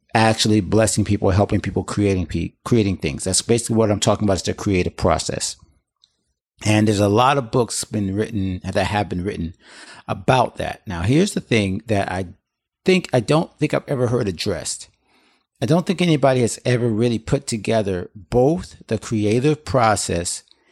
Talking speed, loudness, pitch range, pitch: 170 wpm, -20 LUFS, 95-125 Hz, 110 Hz